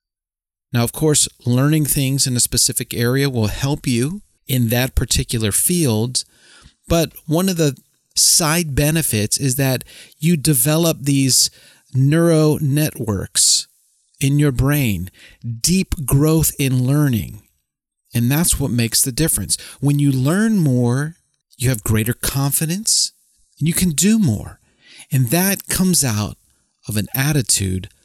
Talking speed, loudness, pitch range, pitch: 135 wpm, -17 LUFS, 120-155 Hz, 135 Hz